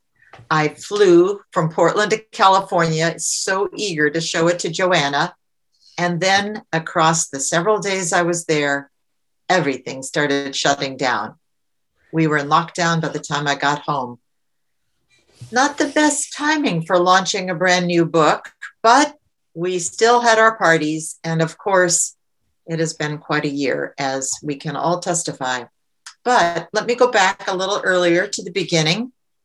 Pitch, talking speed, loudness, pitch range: 170 Hz, 155 wpm, -18 LUFS, 150-195 Hz